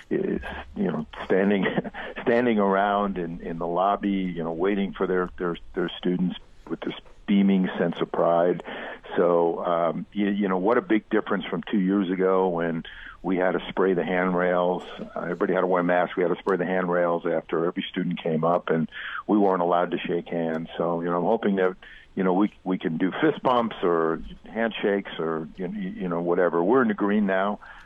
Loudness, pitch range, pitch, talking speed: -25 LUFS, 85-100 Hz, 90 Hz, 200 wpm